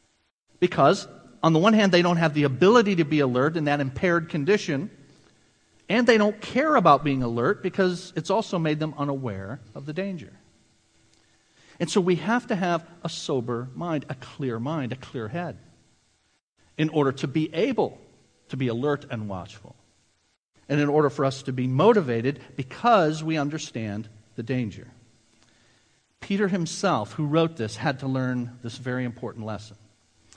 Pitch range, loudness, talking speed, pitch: 120-170 Hz, -24 LUFS, 165 wpm, 140 Hz